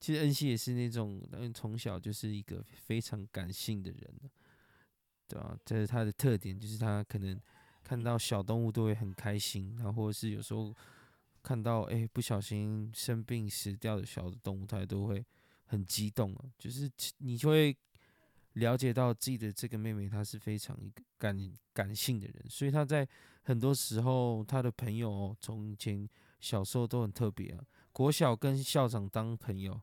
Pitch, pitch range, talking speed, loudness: 110 Hz, 105-125 Hz, 260 characters per minute, -36 LUFS